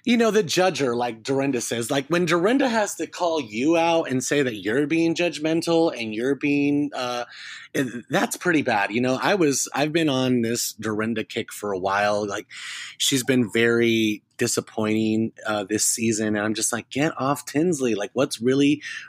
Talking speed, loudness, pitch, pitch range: 185 wpm, -23 LUFS, 130 Hz, 115-155 Hz